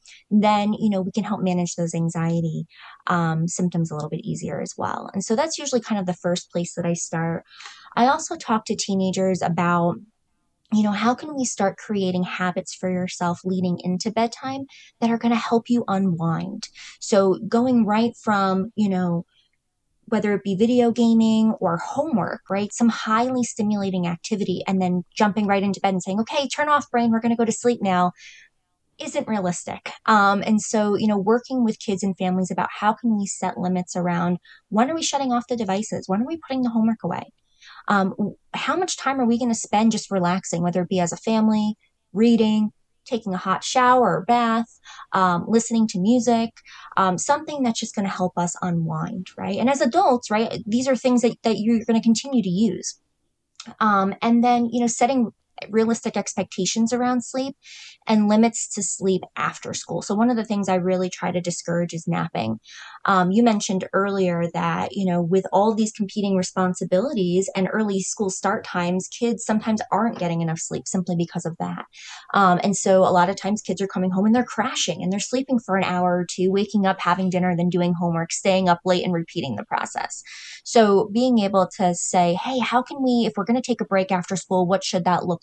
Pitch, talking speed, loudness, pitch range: 200 Hz, 205 wpm, -22 LUFS, 180-230 Hz